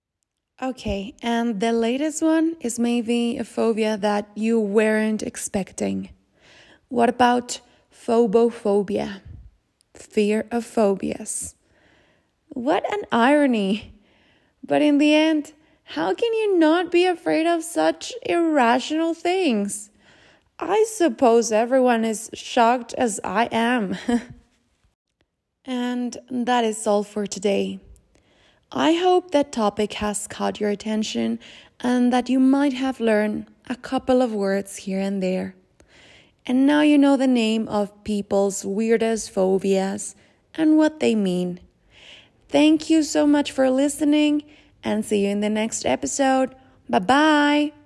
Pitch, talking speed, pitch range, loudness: 235 Hz, 125 wpm, 210-290 Hz, -21 LUFS